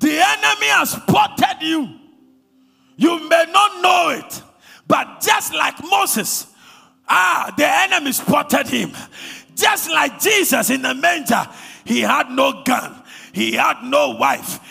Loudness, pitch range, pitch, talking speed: -16 LUFS, 270-380 Hz, 325 Hz, 135 wpm